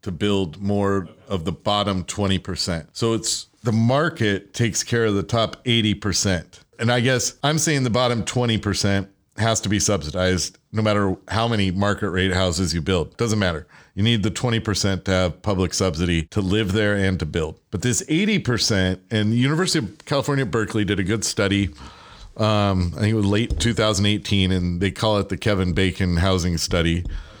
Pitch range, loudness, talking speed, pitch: 95-115 Hz, -21 LUFS, 195 wpm, 100 Hz